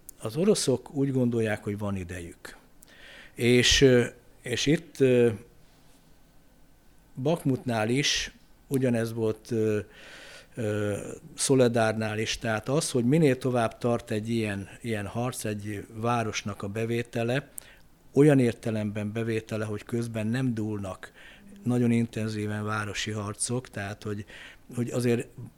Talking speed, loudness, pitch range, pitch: 105 wpm, -27 LUFS, 105-125 Hz, 115 Hz